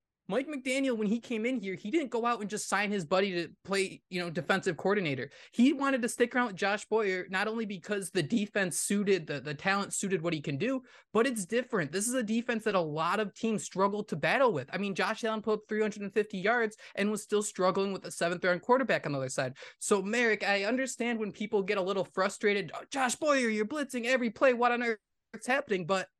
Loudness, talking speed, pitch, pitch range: -31 LUFS, 235 wpm, 210 Hz, 190-235 Hz